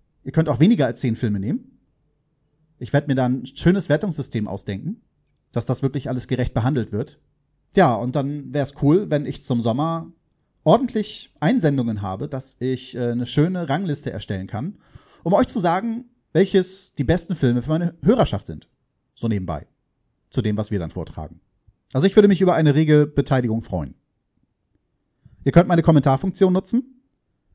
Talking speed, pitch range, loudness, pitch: 170 wpm, 120-170 Hz, -21 LUFS, 140 Hz